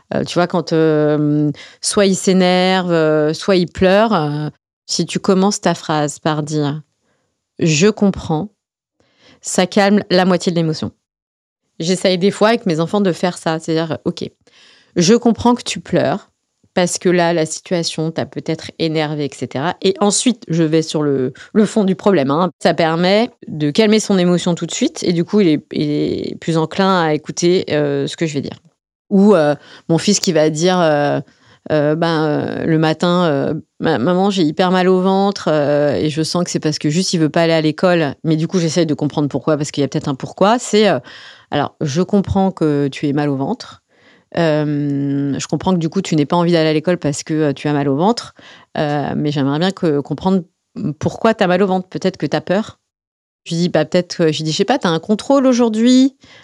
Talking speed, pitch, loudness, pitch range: 215 wpm, 170 Hz, -16 LUFS, 150-190 Hz